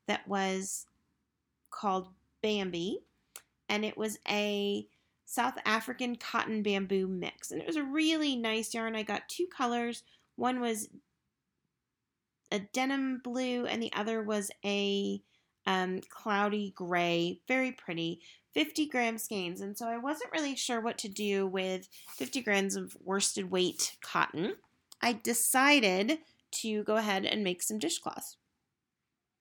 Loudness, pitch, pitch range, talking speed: -32 LUFS, 215 Hz, 195-240 Hz, 135 wpm